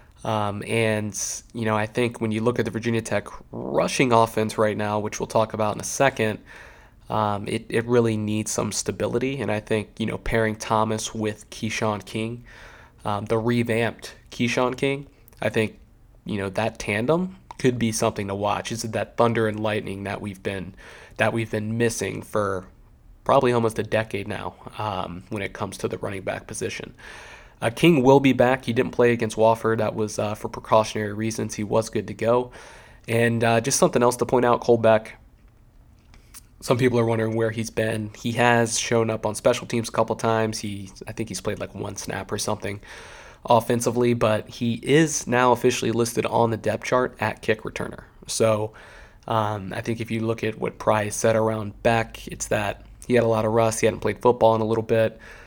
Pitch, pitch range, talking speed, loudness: 110 Hz, 105-120 Hz, 200 wpm, -23 LUFS